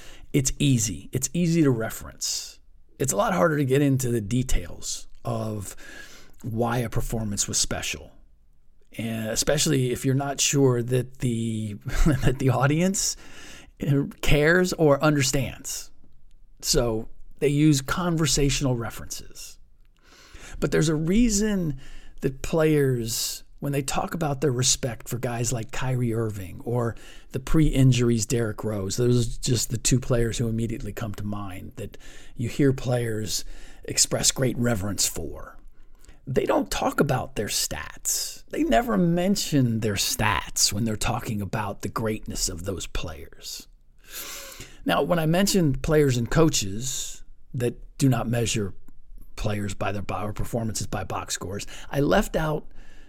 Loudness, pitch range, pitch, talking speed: -25 LUFS, 110-140 Hz, 120 Hz, 140 wpm